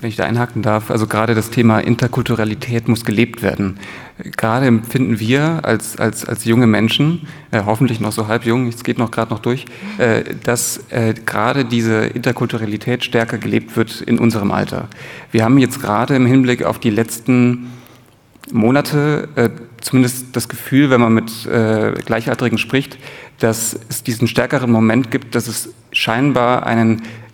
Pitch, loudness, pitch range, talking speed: 115 Hz, -16 LUFS, 110-125 Hz, 165 wpm